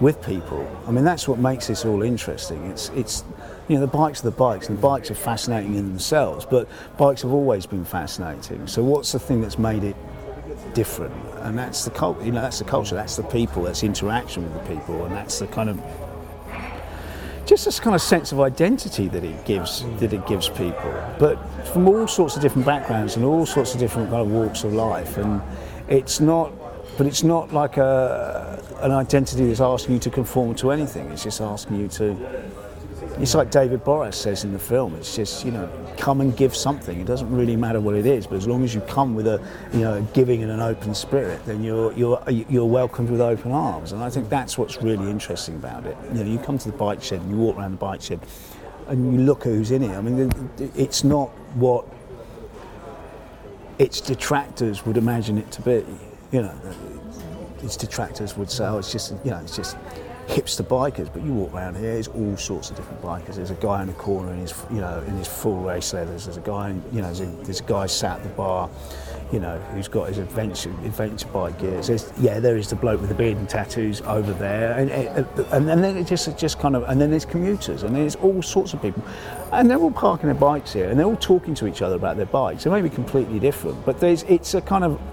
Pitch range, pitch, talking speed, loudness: 100-135 Hz, 115 Hz, 235 wpm, -23 LUFS